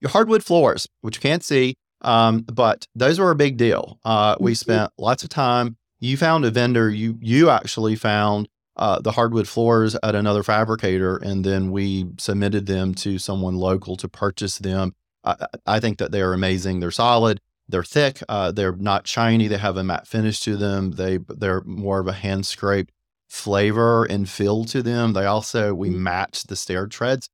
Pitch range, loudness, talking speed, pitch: 95-115 Hz, -21 LUFS, 190 wpm, 105 Hz